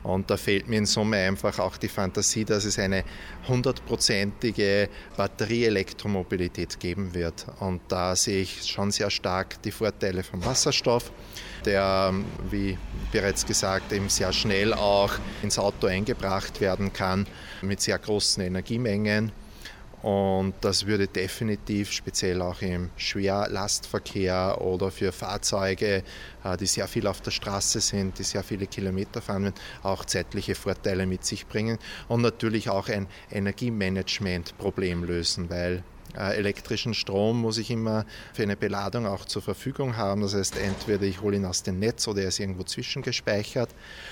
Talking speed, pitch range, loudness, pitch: 145 wpm, 95-105 Hz, -27 LUFS, 100 Hz